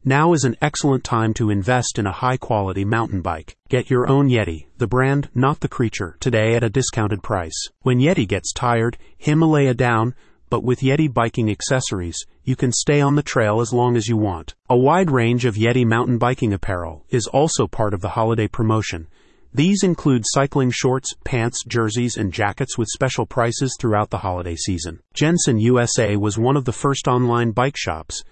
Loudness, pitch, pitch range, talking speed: -19 LUFS, 120 Hz, 105-130 Hz, 190 wpm